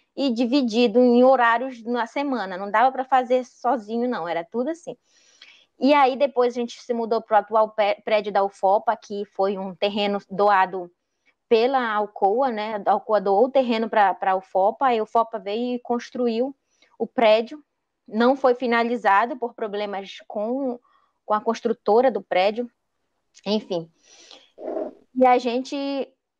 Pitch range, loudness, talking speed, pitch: 205-255 Hz, -22 LUFS, 150 wpm, 230 Hz